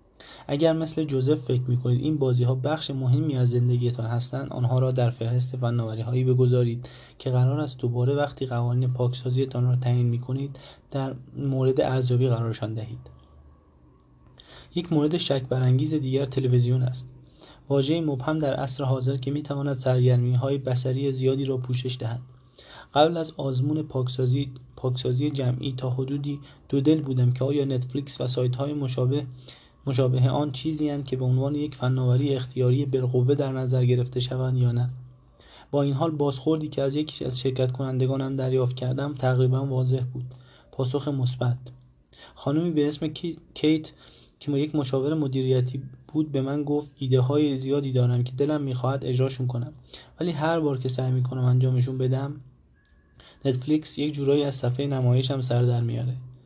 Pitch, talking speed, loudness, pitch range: 130 Hz, 155 wpm, -25 LUFS, 125-140 Hz